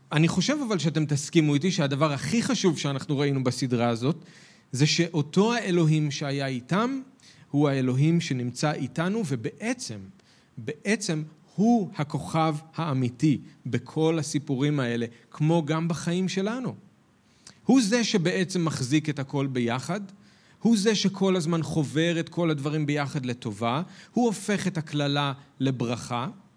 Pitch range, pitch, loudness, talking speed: 140-180 Hz, 155 Hz, -26 LUFS, 125 wpm